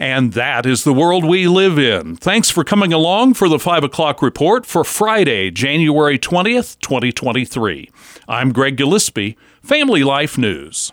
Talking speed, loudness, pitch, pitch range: 155 wpm, -14 LUFS, 150 Hz, 130-180 Hz